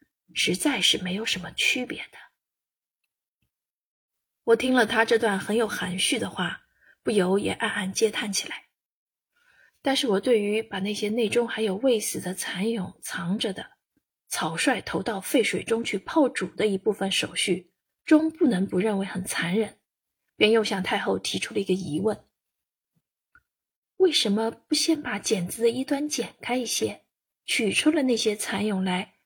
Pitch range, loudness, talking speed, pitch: 195-245 Hz, -25 LUFS, 230 characters per minute, 220 Hz